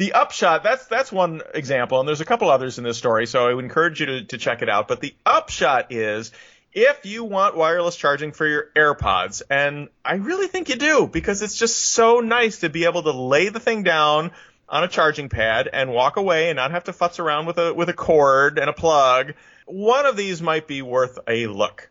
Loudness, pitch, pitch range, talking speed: -20 LUFS, 160 Hz, 135-195 Hz, 230 wpm